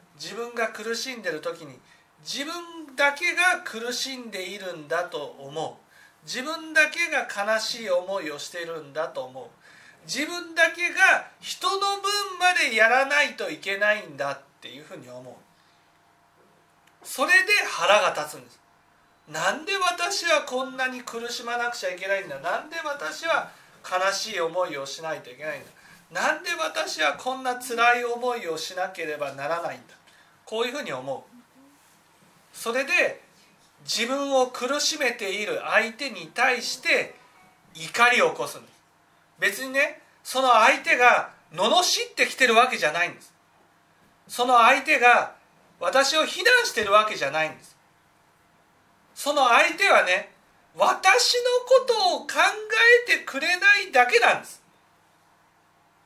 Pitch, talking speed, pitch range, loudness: 250 Hz, 280 characters per minute, 195-320 Hz, -23 LUFS